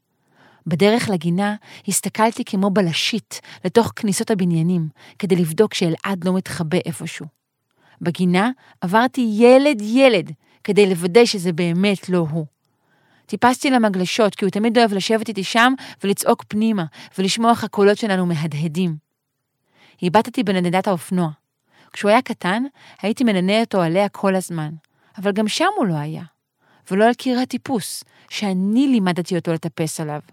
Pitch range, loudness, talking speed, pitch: 170-220 Hz, -19 LUFS, 135 wpm, 195 Hz